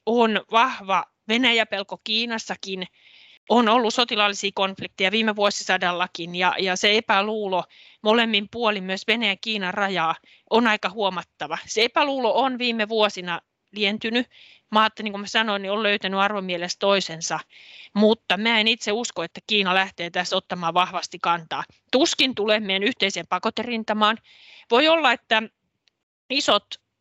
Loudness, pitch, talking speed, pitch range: -22 LUFS, 210 Hz, 135 wpm, 190-225 Hz